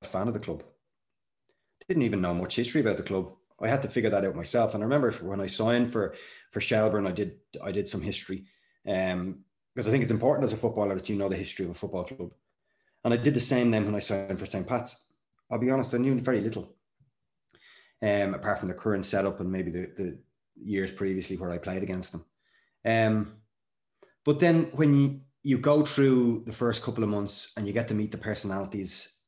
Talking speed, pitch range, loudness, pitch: 220 wpm, 95-120 Hz, -28 LUFS, 105 Hz